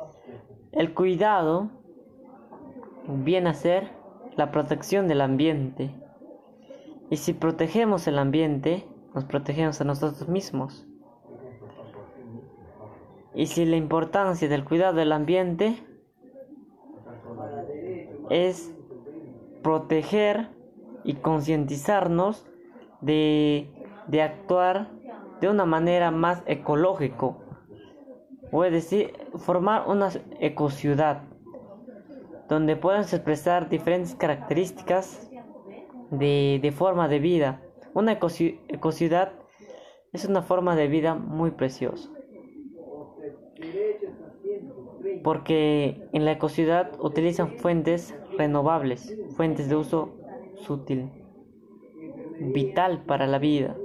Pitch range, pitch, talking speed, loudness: 150-195 Hz, 165 Hz, 90 wpm, -25 LUFS